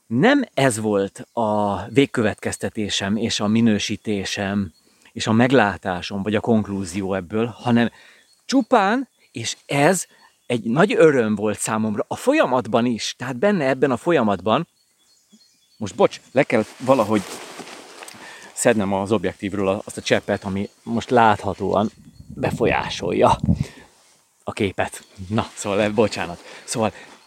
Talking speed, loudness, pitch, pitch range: 115 wpm, -21 LUFS, 110 Hz, 100-120 Hz